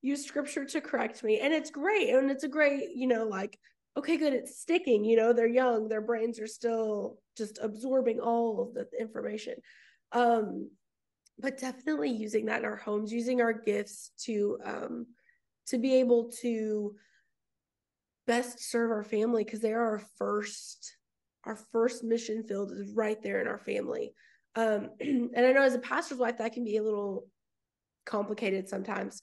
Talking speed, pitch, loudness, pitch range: 170 wpm, 235 Hz, -31 LUFS, 220-260 Hz